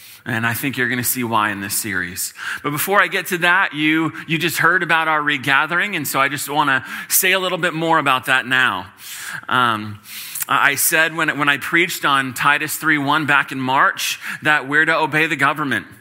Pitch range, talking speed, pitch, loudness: 130-160 Hz, 215 wpm, 150 Hz, -17 LUFS